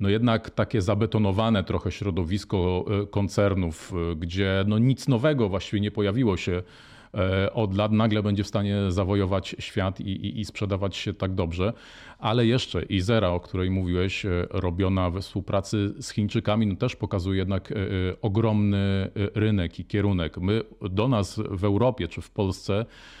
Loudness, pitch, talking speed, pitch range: -26 LUFS, 100 Hz, 145 wpm, 95-110 Hz